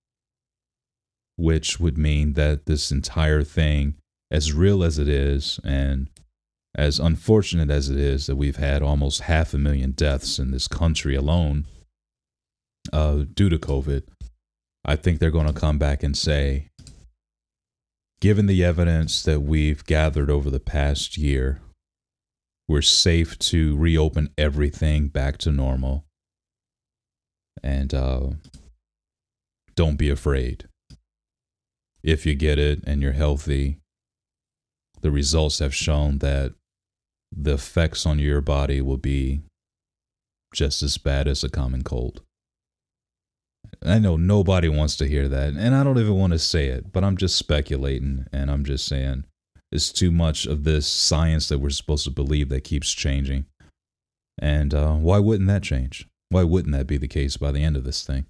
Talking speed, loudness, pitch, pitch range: 150 wpm, -22 LUFS, 75 Hz, 70-85 Hz